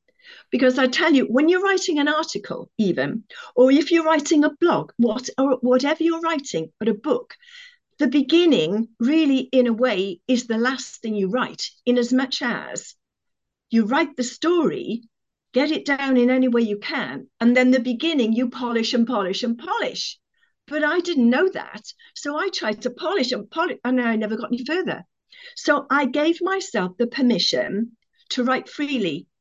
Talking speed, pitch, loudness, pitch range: 180 wpm, 260 Hz, -21 LUFS, 235-320 Hz